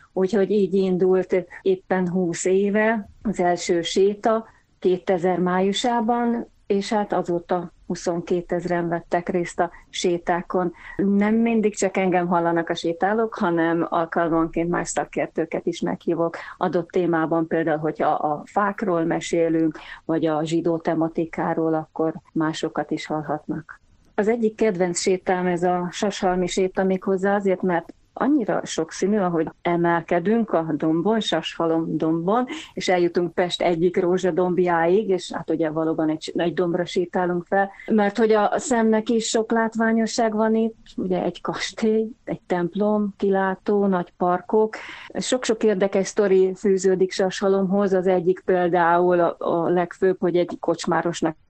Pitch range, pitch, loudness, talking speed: 170-200 Hz, 180 Hz, -22 LUFS, 130 wpm